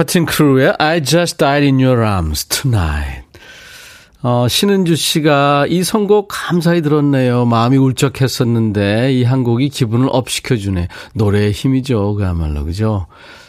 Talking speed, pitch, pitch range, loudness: 350 characters per minute, 130 Hz, 110-150 Hz, -14 LUFS